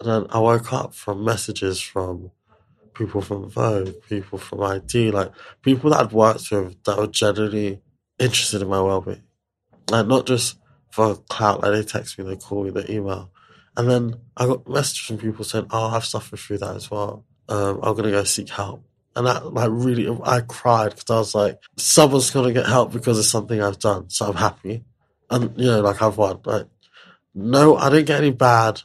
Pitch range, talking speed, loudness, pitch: 100-125 Hz, 205 wpm, -20 LUFS, 110 Hz